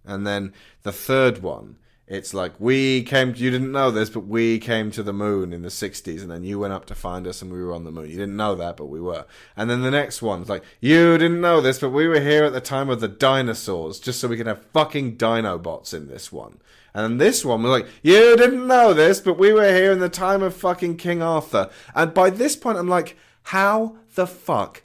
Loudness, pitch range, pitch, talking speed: -19 LUFS, 100-170 Hz, 125 Hz, 245 wpm